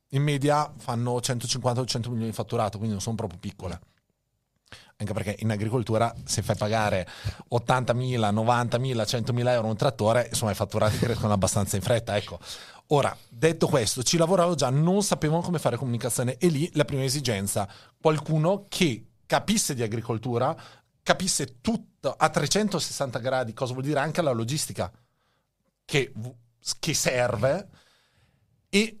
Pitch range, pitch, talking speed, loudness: 110-150 Hz, 125 Hz, 145 wpm, -26 LUFS